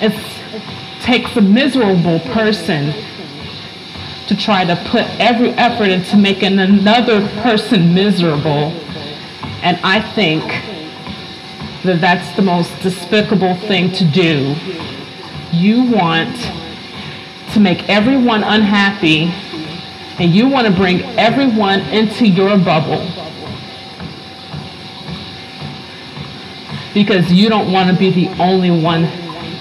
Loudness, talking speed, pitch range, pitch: -13 LUFS, 105 wpm, 175-215 Hz, 190 Hz